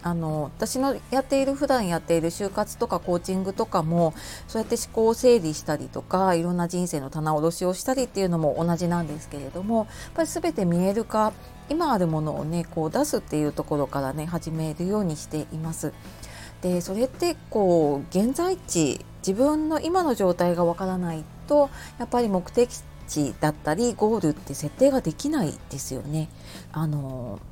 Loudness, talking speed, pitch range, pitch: -25 LUFS, 365 characters per minute, 155-225 Hz, 175 Hz